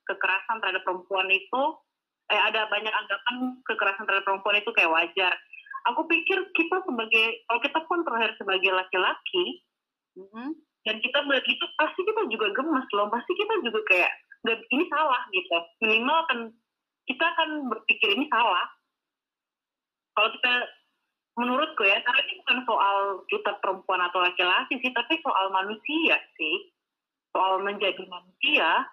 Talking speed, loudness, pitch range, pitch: 140 wpm, -25 LUFS, 195-315 Hz, 230 Hz